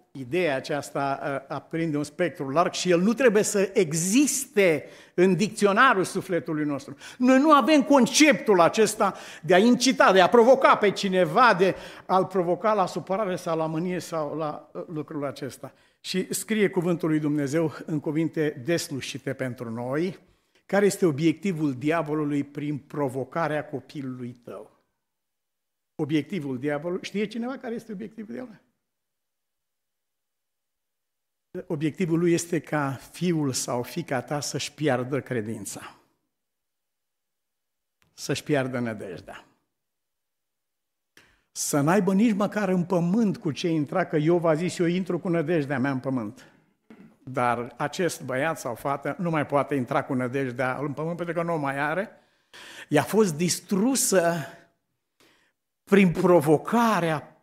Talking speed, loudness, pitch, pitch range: 130 wpm, -24 LUFS, 165 Hz, 140-185 Hz